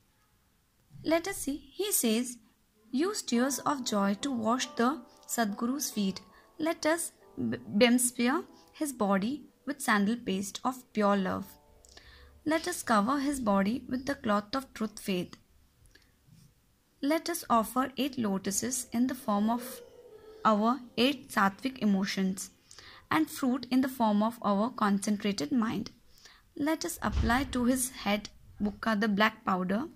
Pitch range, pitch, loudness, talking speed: 210-275 Hz, 245 Hz, -30 LUFS, 135 wpm